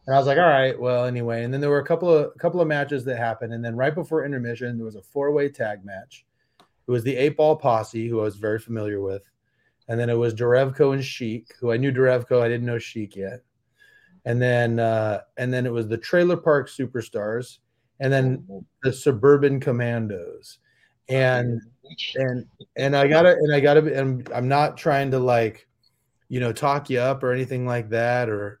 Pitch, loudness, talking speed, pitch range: 125 Hz, -22 LUFS, 210 wpm, 115-140 Hz